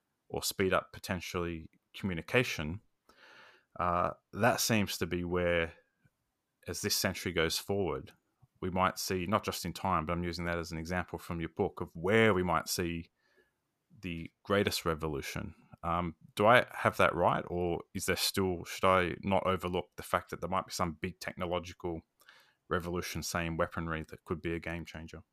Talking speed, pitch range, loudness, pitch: 175 wpm, 85-95 Hz, -33 LUFS, 85 Hz